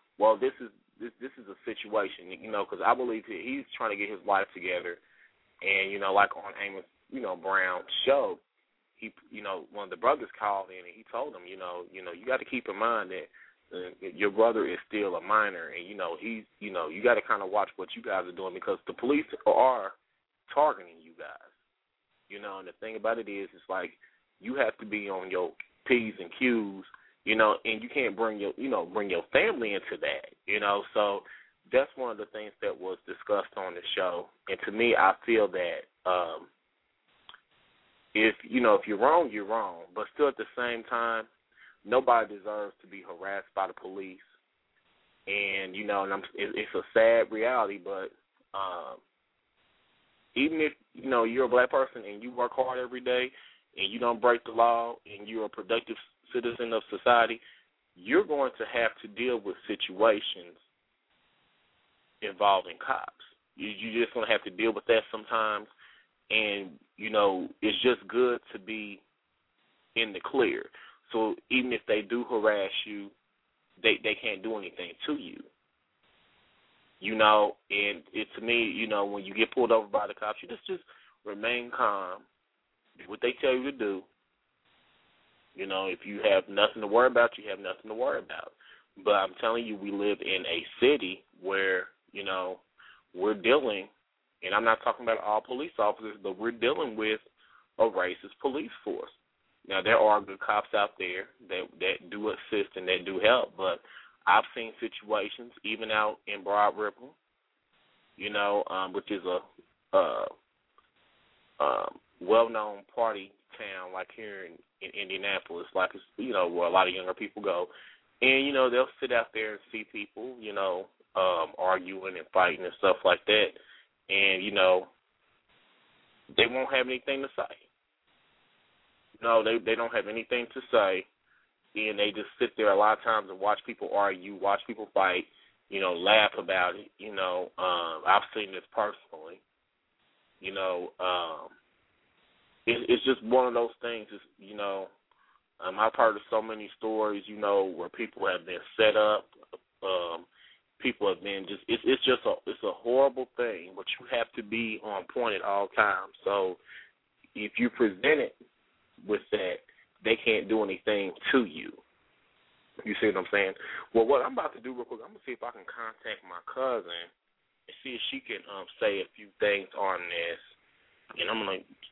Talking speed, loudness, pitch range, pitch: 185 wpm, -29 LUFS, 100-130 Hz, 110 Hz